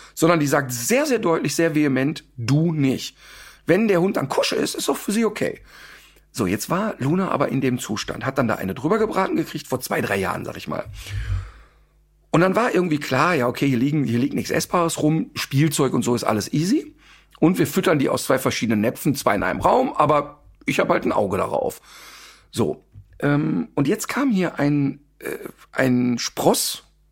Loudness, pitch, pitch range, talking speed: -21 LUFS, 145 Hz, 120-165 Hz, 205 wpm